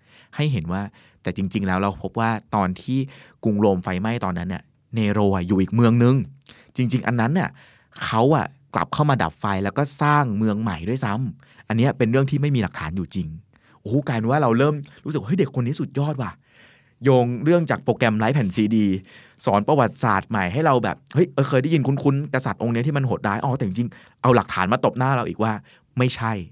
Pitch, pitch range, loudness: 120 Hz, 105-135 Hz, -22 LUFS